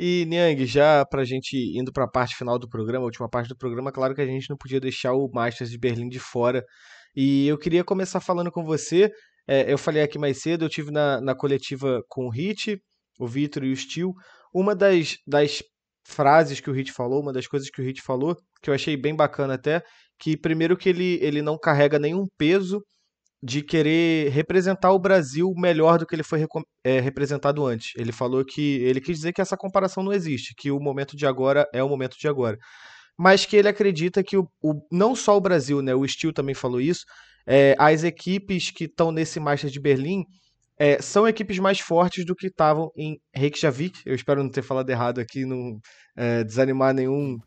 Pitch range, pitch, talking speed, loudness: 130-175 Hz, 145 Hz, 210 wpm, -23 LUFS